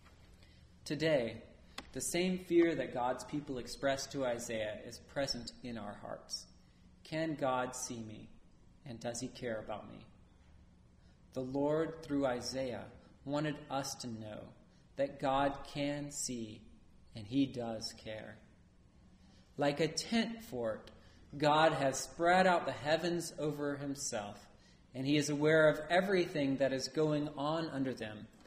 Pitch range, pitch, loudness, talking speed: 115-150 Hz, 135 Hz, -36 LUFS, 135 wpm